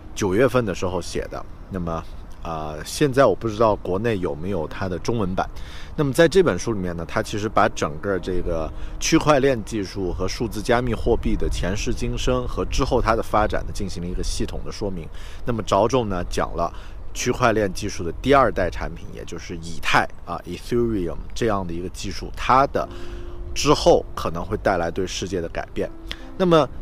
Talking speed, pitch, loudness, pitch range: 305 characters per minute, 95 Hz, -23 LUFS, 85-115 Hz